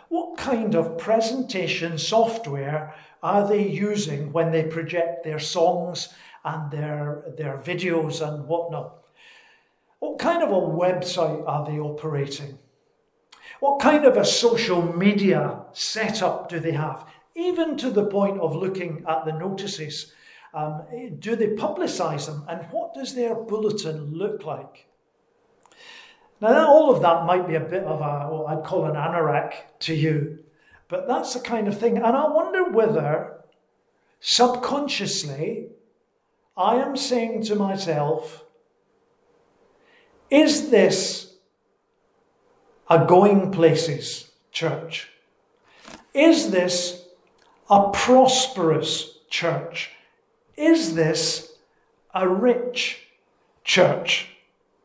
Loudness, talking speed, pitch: -22 LUFS, 115 wpm, 195 Hz